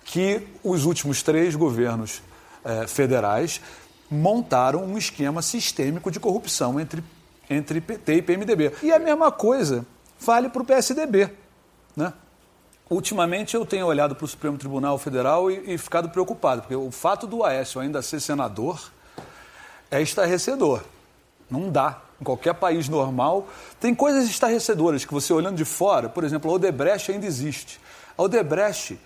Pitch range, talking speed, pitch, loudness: 145-200 Hz, 150 wpm, 170 Hz, -23 LUFS